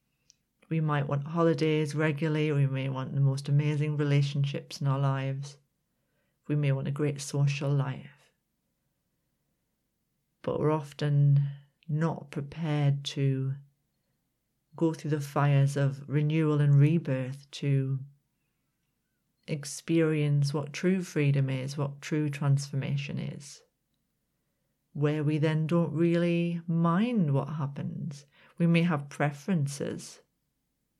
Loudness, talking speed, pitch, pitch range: -29 LUFS, 110 wpm, 145 Hz, 140-160 Hz